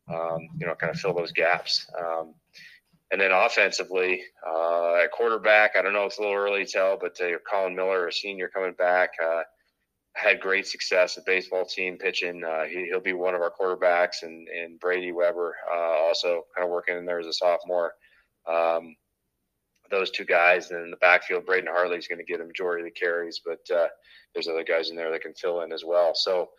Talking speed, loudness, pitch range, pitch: 210 wpm, -25 LUFS, 85-100 Hz, 90 Hz